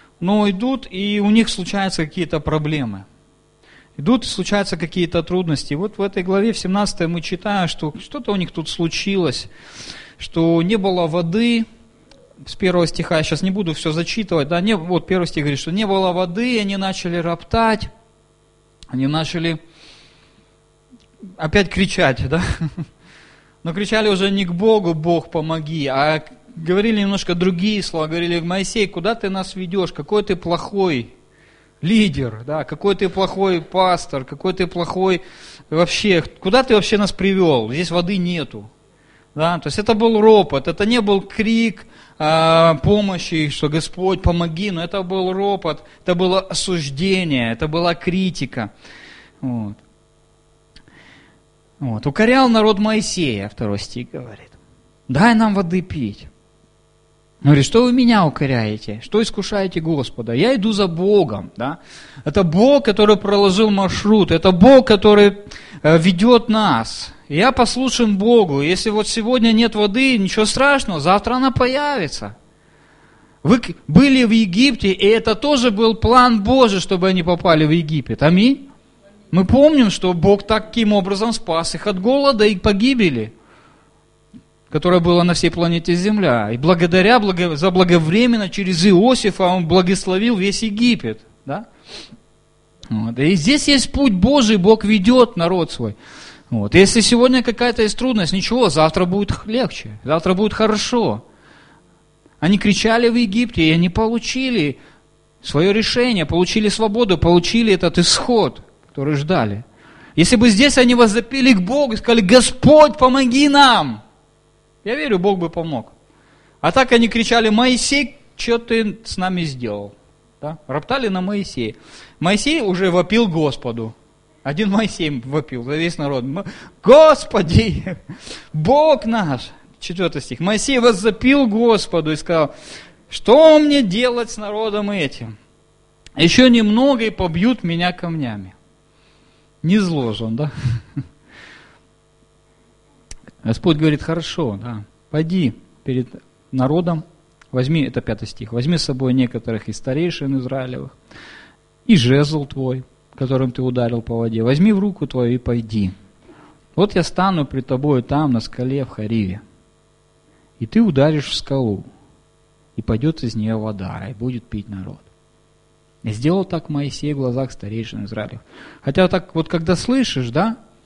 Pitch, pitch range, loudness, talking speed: 180 Hz, 150-215 Hz, -16 LUFS, 140 wpm